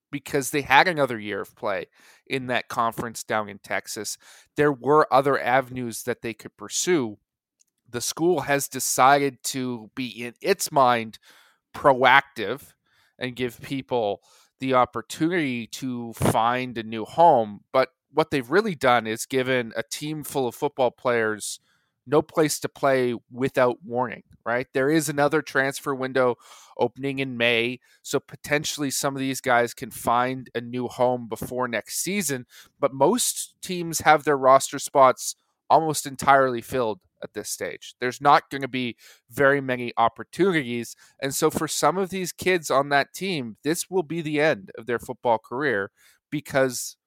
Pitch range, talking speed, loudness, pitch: 120-145 Hz, 160 wpm, -24 LUFS, 130 Hz